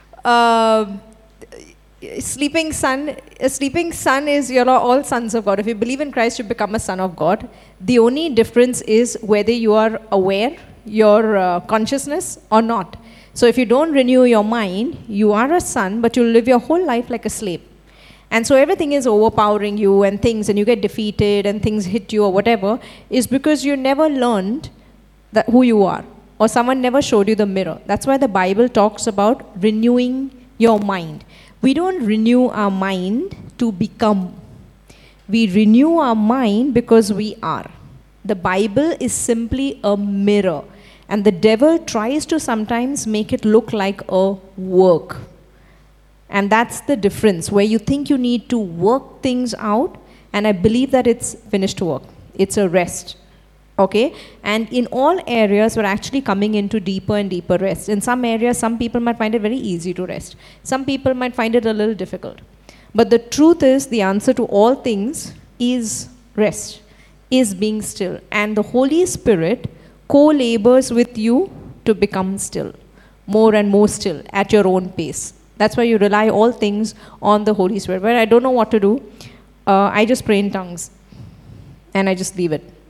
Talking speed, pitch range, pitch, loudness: 180 wpm, 205-245 Hz, 220 Hz, -16 LUFS